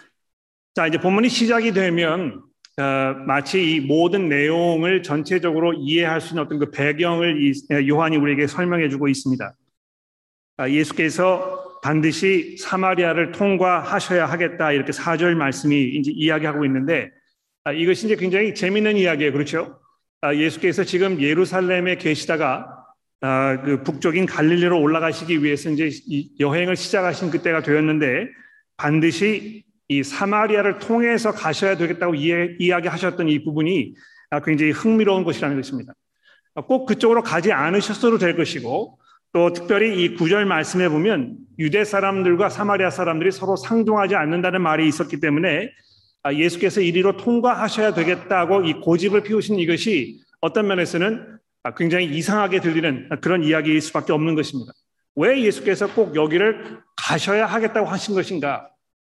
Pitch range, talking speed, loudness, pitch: 155-200 Hz, 355 characters per minute, -20 LUFS, 175 Hz